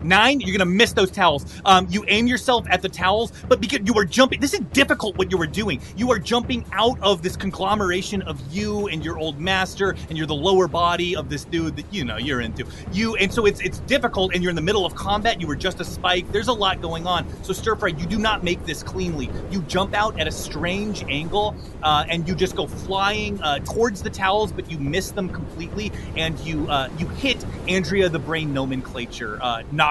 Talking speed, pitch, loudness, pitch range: 235 wpm, 190 Hz, -22 LUFS, 170-210 Hz